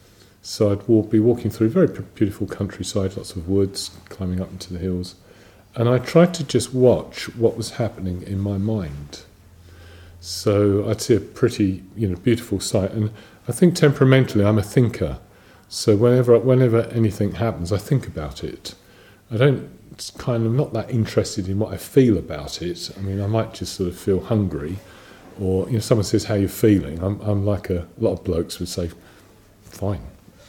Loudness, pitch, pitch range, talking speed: -21 LUFS, 100 Hz, 95-110 Hz, 190 wpm